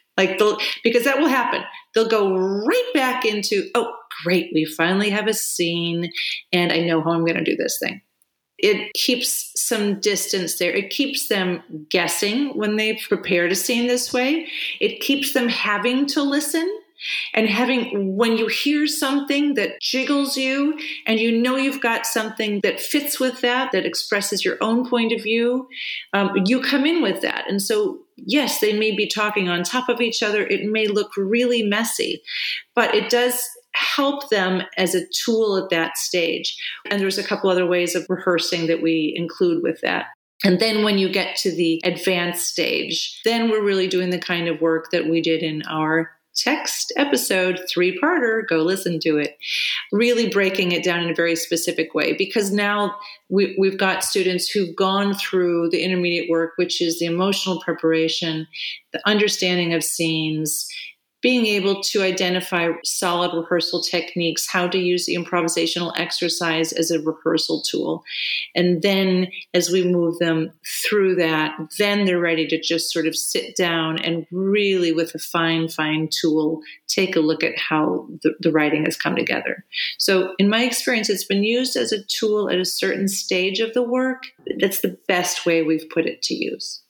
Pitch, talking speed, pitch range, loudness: 190 Hz, 180 wpm, 170-230 Hz, -20 LUFS